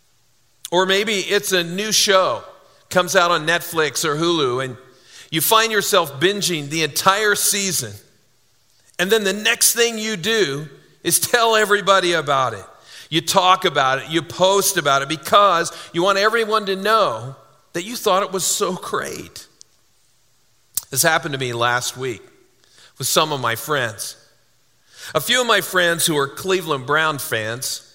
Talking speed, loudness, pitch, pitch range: 160 wpm, -18 LUFS, 170 Hz, 135-200 Hz